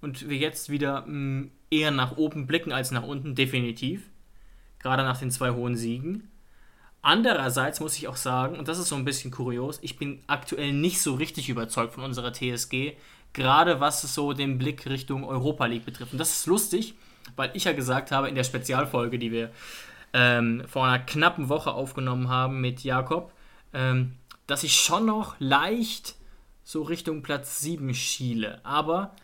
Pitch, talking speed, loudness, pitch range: 140 Hz, 170 wpm, -27 LUFS, 130-155 Hz